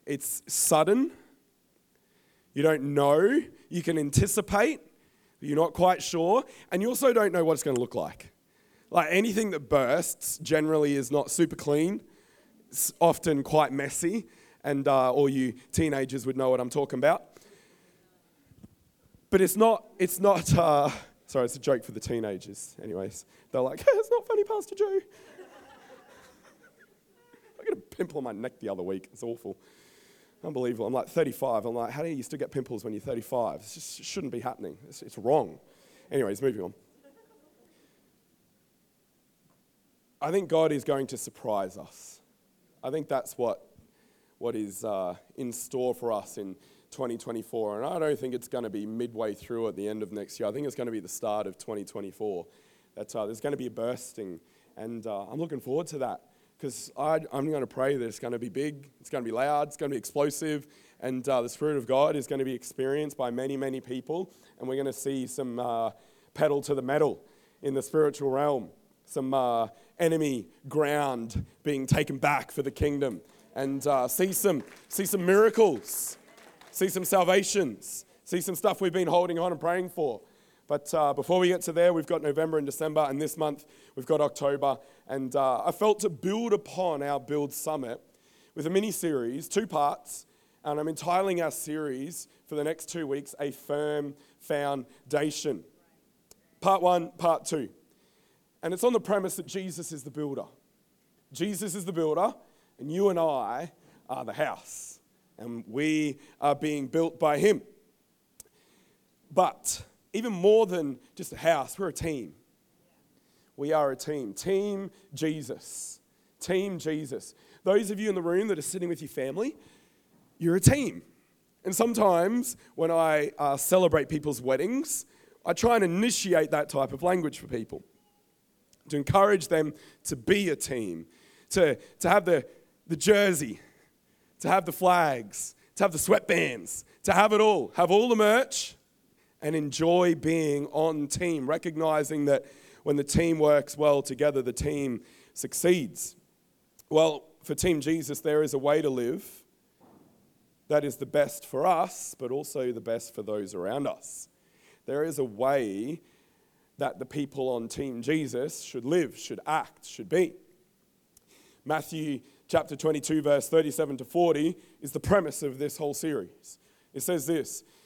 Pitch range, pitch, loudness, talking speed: 140-180 Hz, 150 Hz, -28 LUFS, 170 wpm